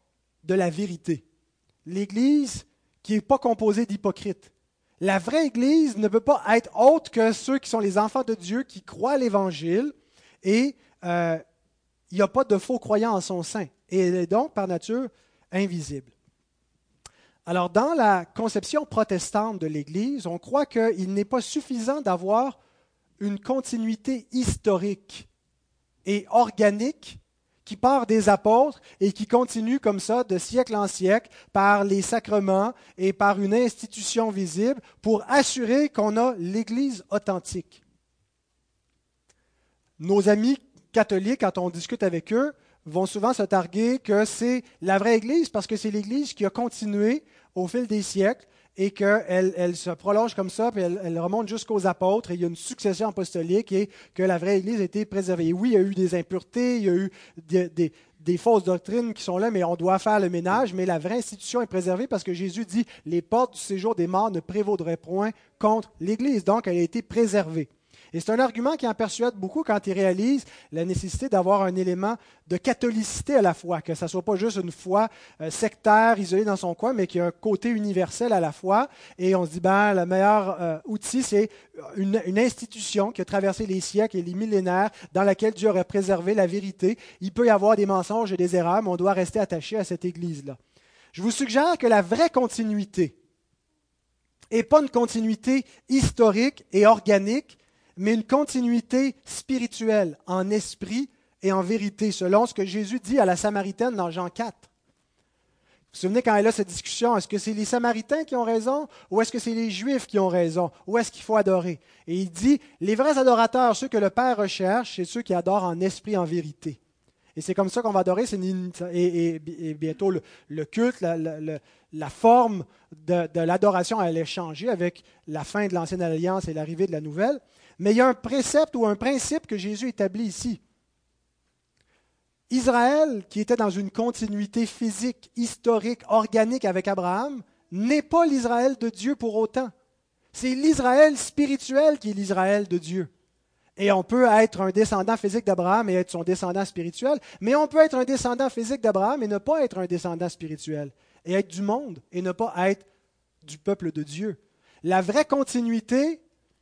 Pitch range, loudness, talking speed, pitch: 185-235 Hz, -24 LUFS, 190 wpm, 205 Hz